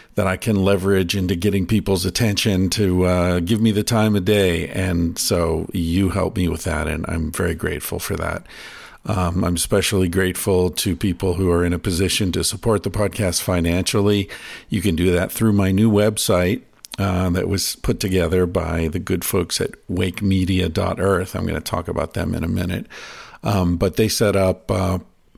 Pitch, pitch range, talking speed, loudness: 95 Hz, 90-100 Hz, 185 wpm, -20 LUFS